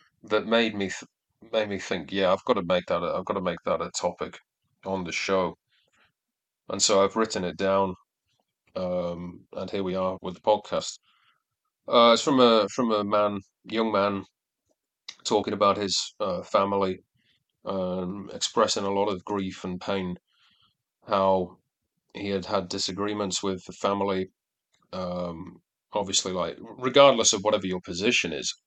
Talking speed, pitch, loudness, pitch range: 160 wpm, 95 Hz, -26 LUFS, 95-105 Hz